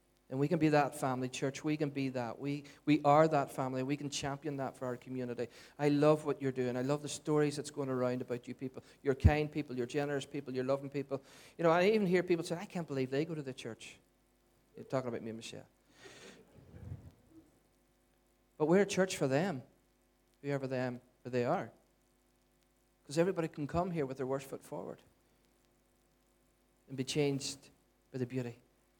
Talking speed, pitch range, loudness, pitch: 195 wpm, 125-150 Hz, -35 LUFS, 140 Hz